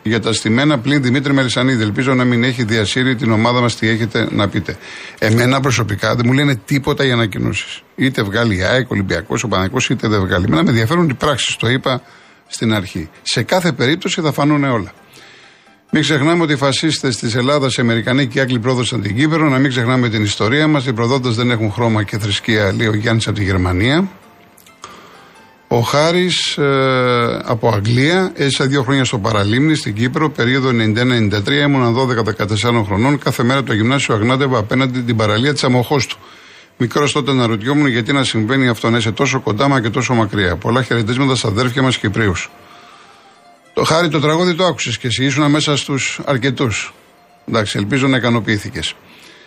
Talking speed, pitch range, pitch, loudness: 180 wpm, 115-140 Hz, 125 Hz, -15 LUFS